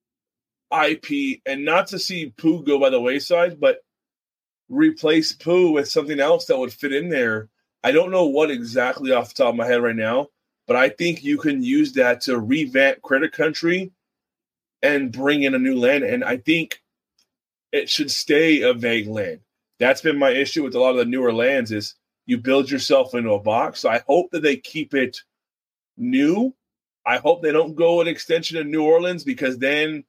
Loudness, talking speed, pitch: -20 LUFS, 195 wpm, 160 Hz